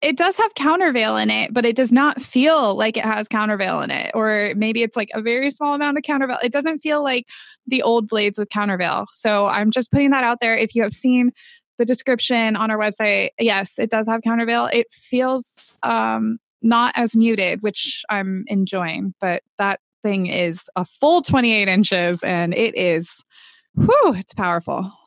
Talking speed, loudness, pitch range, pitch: 190 wpm, -19 LUFS, 200-255 Hz, 225 Hz